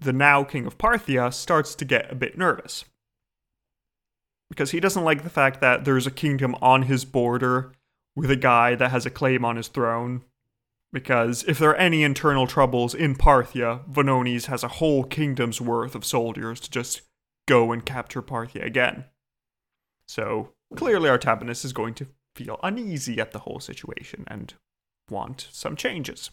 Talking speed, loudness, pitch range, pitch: 170 wpm, -23 LUFS, 120-145 Hz, 130 Hz